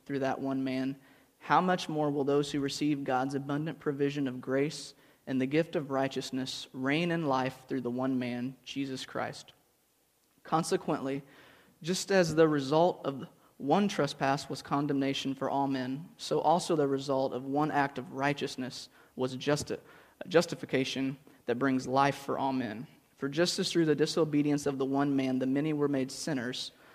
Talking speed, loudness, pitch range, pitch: 170 wpm, -31 LUFS, 130-150 Hz, 140 Hz